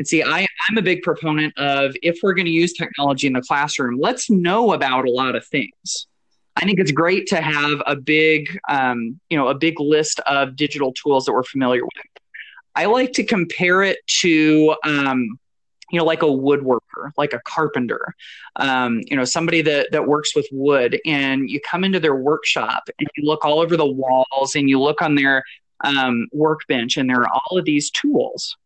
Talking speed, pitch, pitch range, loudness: 200 wpm, 150 Hz, 135-170 Hz, -18 LUFS